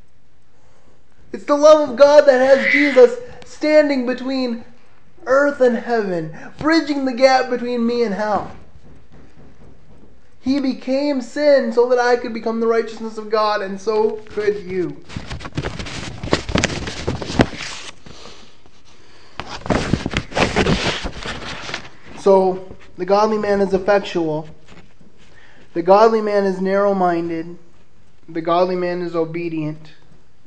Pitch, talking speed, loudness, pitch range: 225 Hz, 105 wpm, -17 LUFS, 185-260 Hz